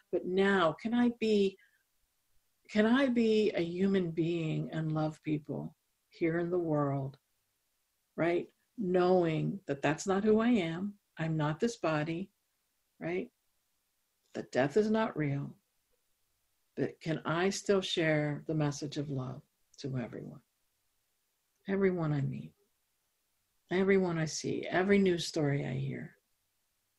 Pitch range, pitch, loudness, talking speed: 145-195 Hz, 165 Hz, -32 LUFS, 130 wpm